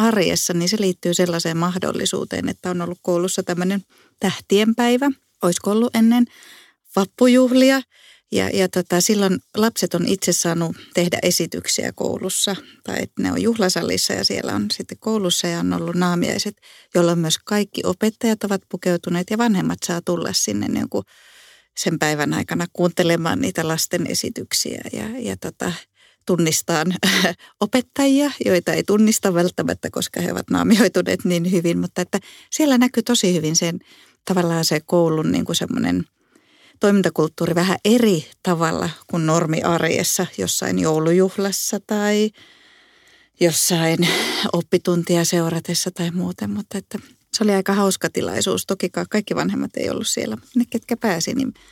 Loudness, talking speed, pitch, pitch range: -20 LUFS, 140 wpm, 185 Hz, 170-215 Hz